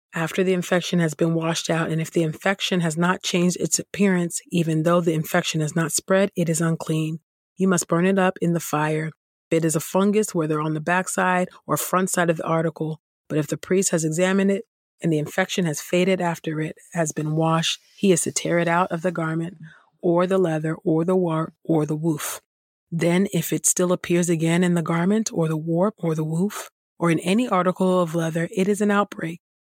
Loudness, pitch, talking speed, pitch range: -22 LUFS, 170 Hz, 220 wpm, 160-185 Hz